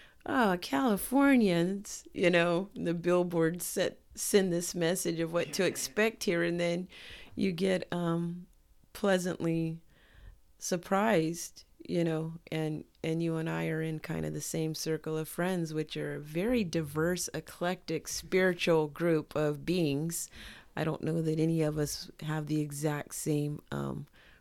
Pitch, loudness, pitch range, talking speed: 165 Hz, -32 LUFS, 155-180 Hz, 145 wpm